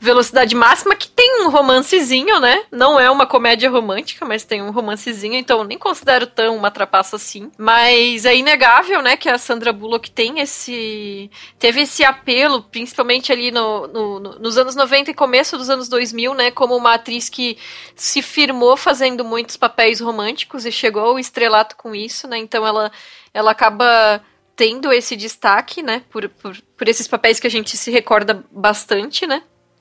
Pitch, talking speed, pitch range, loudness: 240 Hz, 175 wpm, 220-260 Hz, -14 LUFS